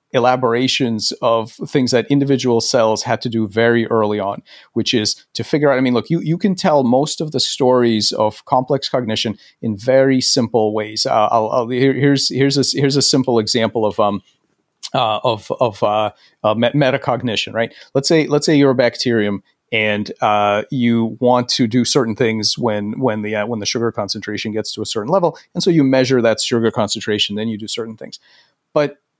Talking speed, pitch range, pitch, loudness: 200 wpm, 110-135 Hz, 120 Hz, -16 LUFS